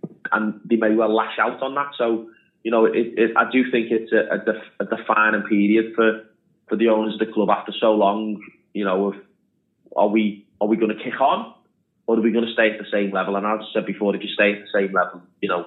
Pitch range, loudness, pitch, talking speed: 100-115 Hz, -21 LUFS, 110 Hz, 255 wpm